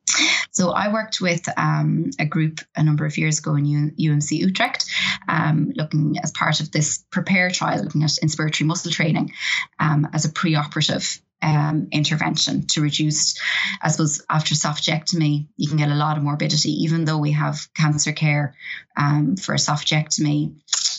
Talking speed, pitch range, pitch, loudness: 165 wpm, 150-165 Hz, 155 Hz, -20 LUFS